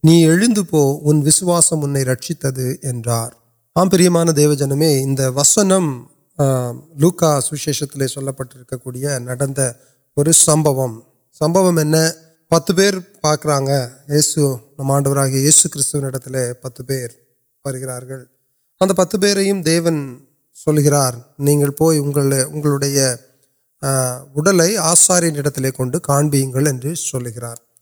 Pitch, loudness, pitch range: 140 Hz, -16 LUFS, 130-160 Hz